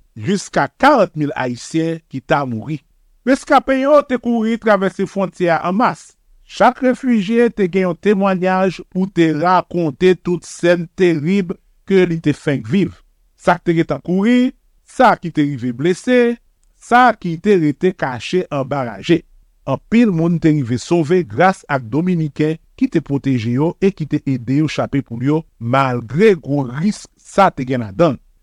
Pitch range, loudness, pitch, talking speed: 145-195 Hz, -16 LUFS, 170 Hz, 165 wpm